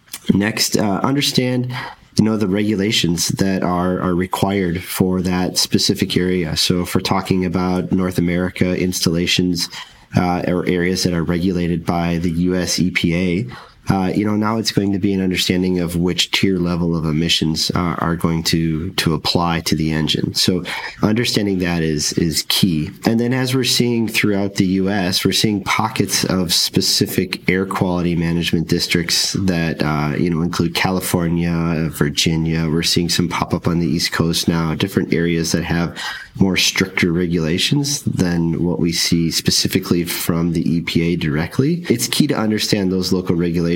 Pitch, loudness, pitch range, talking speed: 90 Hz, -17 LUFS, 85-95 Hz, 165 wpm